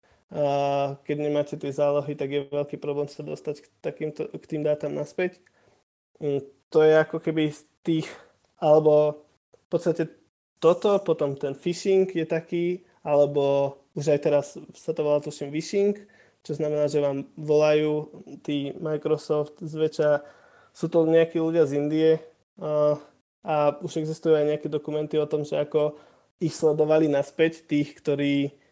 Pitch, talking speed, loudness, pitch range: 150 Hz, 140 wpm, -25 LUFS, 145-160 Hz